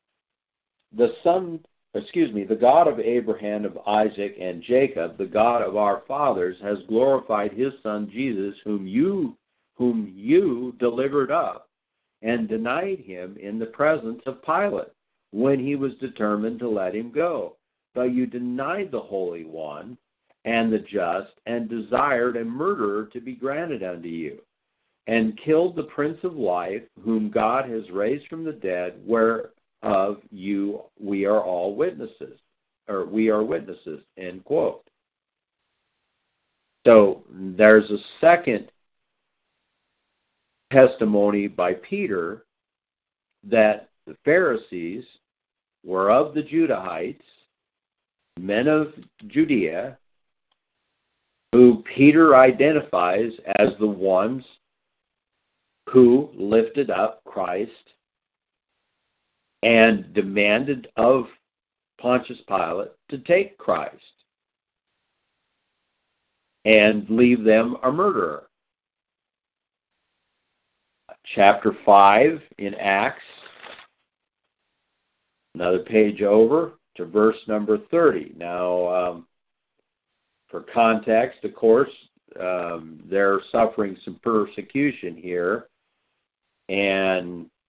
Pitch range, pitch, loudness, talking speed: 100-130 Hz, 110 Hz, -21 LUFS, 105 wpm